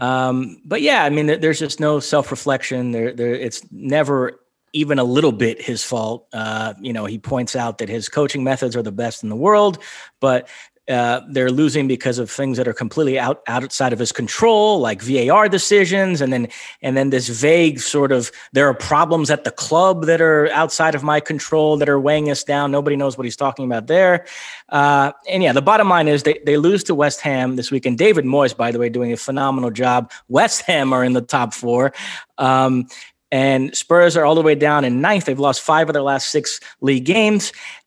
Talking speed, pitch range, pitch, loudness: 215 wpm, 125-150 Hz, 135 Hz, -17 LUFS